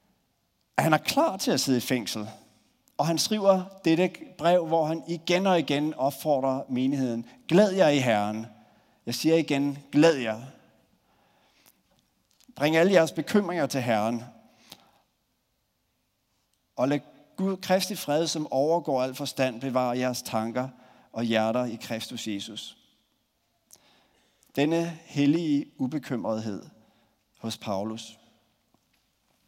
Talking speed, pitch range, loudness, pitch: 115 wpm, 115-165 Hz, -26 LUFS, 135 Hz